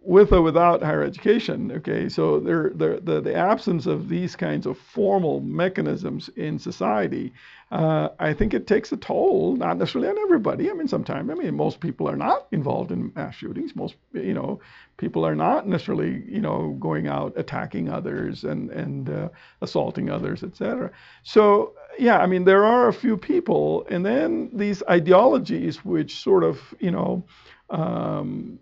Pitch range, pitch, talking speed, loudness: 180-280 Hz, 205 Hz, 170 wpm, -23 LUFS